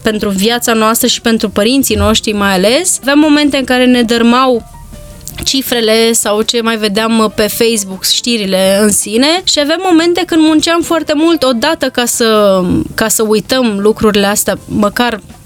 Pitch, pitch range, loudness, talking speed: 230 Hz, 215-270 Hz, -10 LUFS, 160 wpm